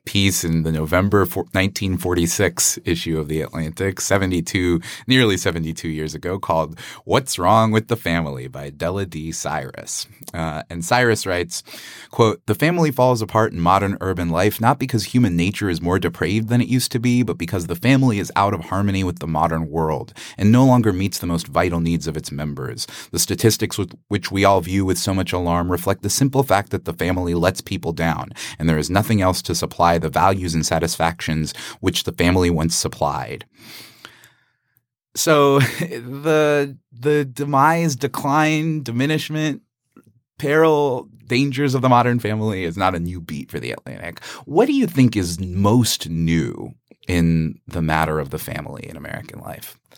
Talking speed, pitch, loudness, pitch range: 175 wpm, 95 Hz, -19 LUFS, 85-120 Hz